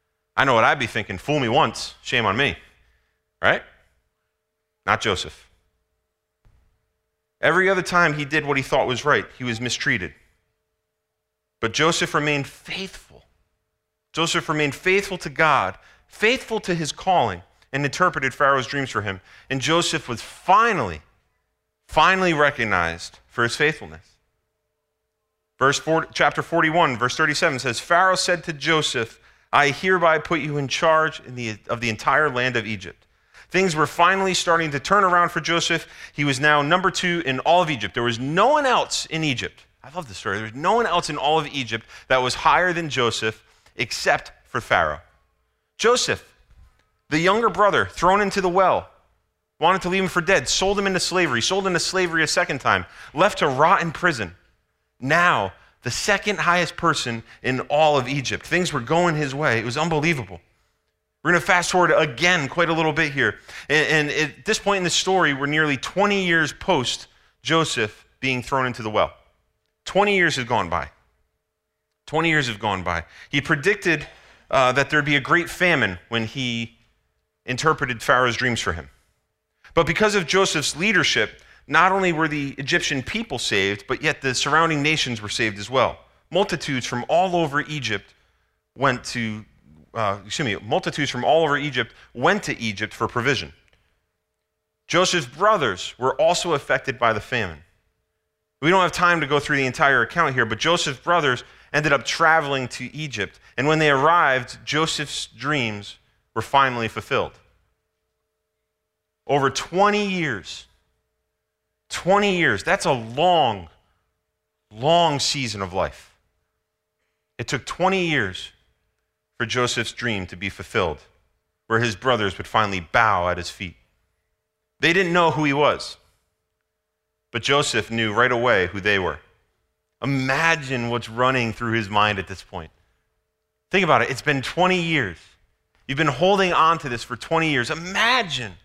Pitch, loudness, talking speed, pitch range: 130 Hz, -21 LUFS, 165 wpm, 100-165 Hz